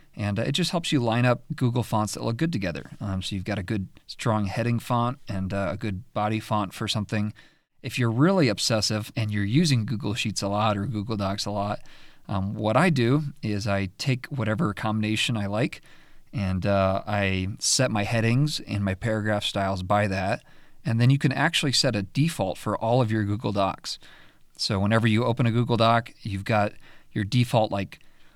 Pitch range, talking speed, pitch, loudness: 100-125 Hz, 200 wpm, 110 Hz, -25 LUFS